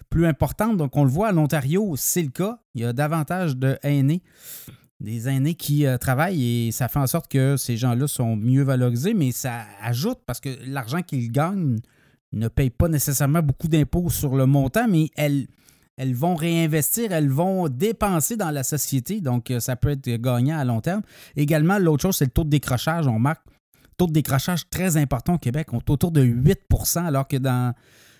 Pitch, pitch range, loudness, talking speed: 140 Hz, 130-165 Hz, -22 LUFS, 200 wpm